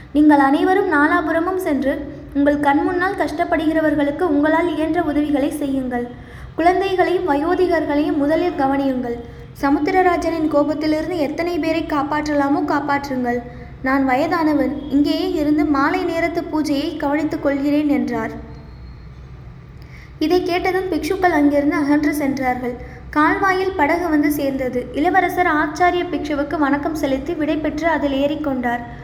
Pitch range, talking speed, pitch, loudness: 285-335 Hz, 105 wpm, 305 Hz, -18 LUFS